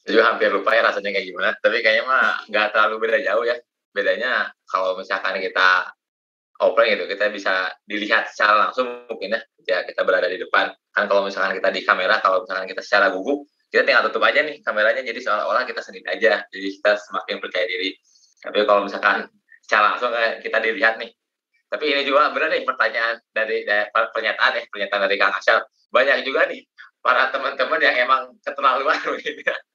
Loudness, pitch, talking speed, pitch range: -20 LUFS, 115 Hz, 180 wpm, 105-145 Hz